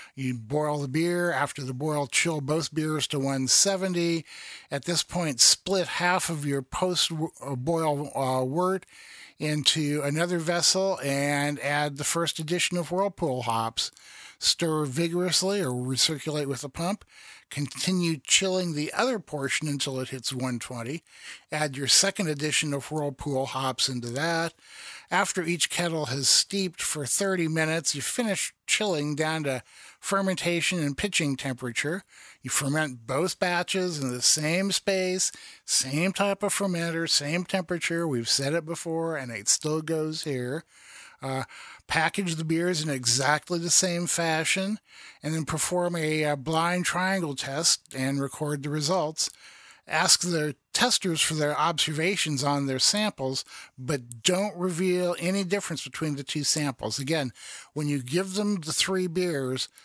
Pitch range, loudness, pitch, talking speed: 140-175 Hz, -26 LUFS, 155 Hz, 145 wpm